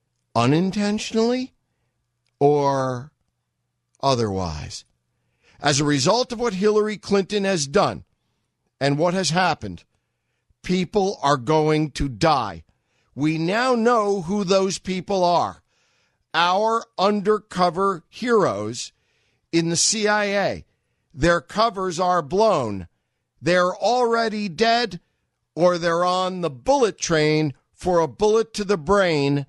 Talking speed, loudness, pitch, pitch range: 110 wpm, -21 LUFS, 175 Hz, 140-205 Hz